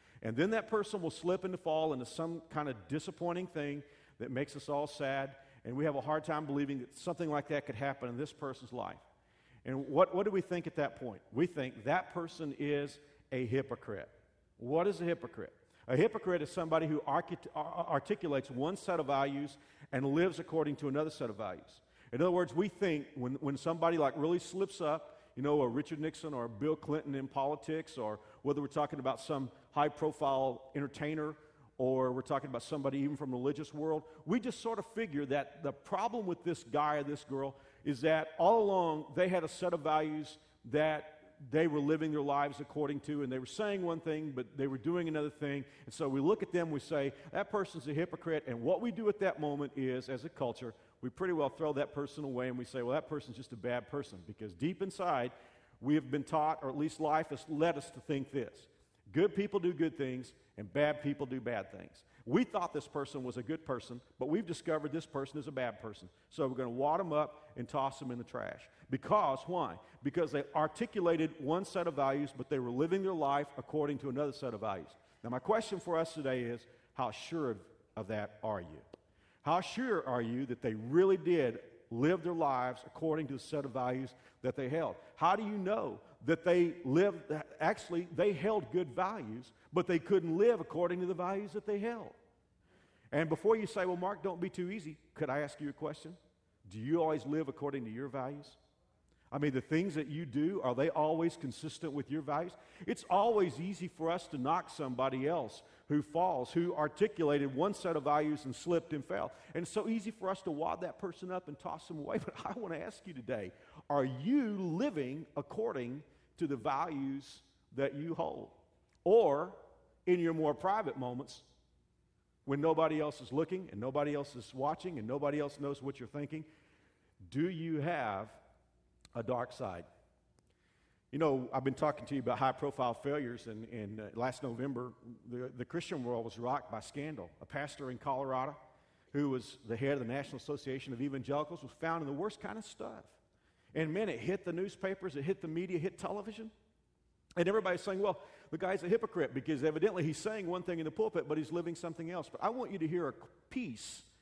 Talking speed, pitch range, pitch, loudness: 210 wpm, 135-170 Hz, 150 Hz, -37 LUFS